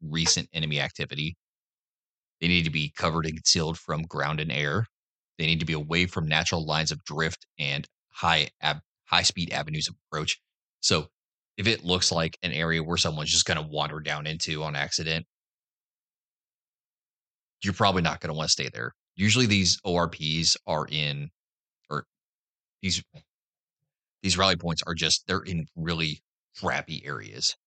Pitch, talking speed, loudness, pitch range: 80 Hz, 160 wpm, -26 LUFS, 80-90 Hz